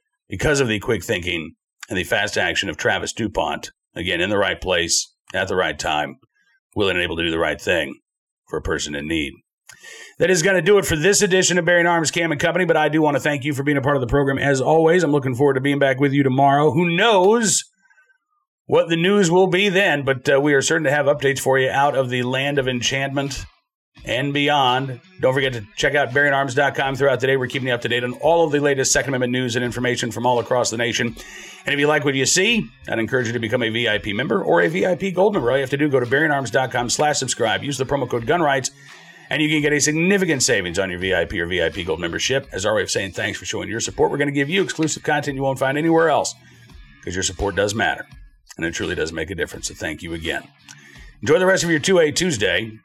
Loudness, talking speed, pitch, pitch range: -19 LUFS, 255 wpm, 145 Hz, 130-170 Hz